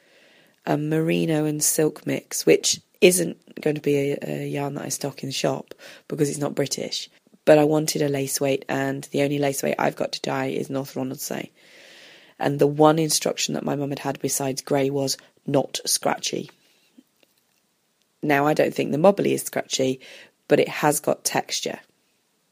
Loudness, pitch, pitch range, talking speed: -23 LUFS, 140 Hz, 135-150 Hz, 180 wpm